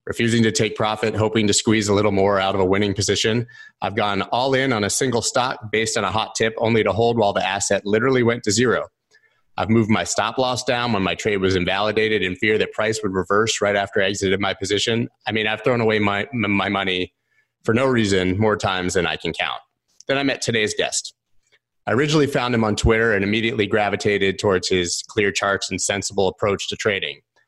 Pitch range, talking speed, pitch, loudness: 100-115 Hz, 220 wpm, 105 Hz, -20 LUFS